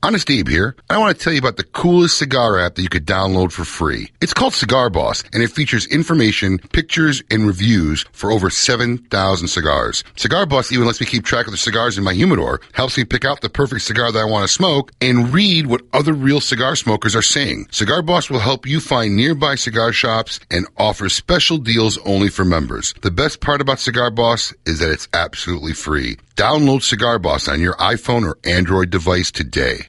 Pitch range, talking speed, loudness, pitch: 95-135 Hz, 210 wpm, -16 LUFS, 115 Hz